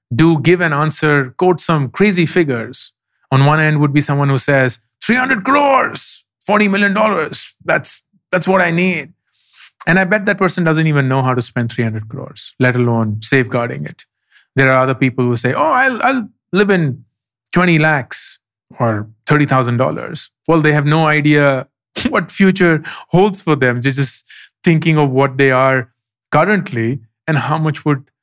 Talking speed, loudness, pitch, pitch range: 175 wpm, -14 LUFS, 150 Hz, 130-175 Hz